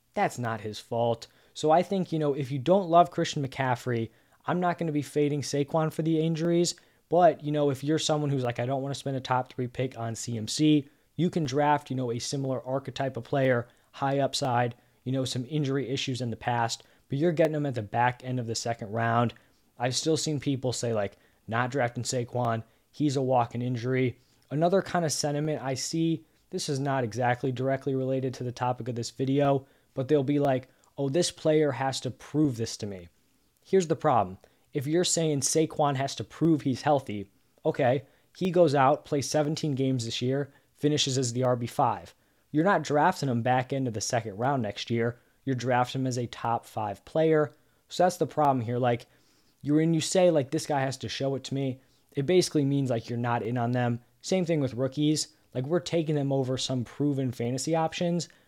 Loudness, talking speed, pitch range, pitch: -28 LUFS, 210 wpm, 120-150 Hz, 135 Hz